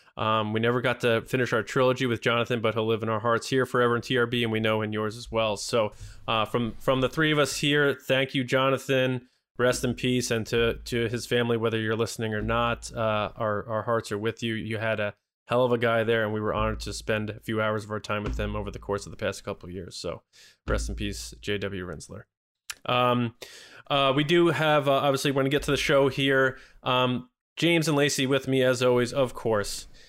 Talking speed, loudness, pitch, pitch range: 240 wpm, -26 LUFS, 120 Hz, 110-130 Hz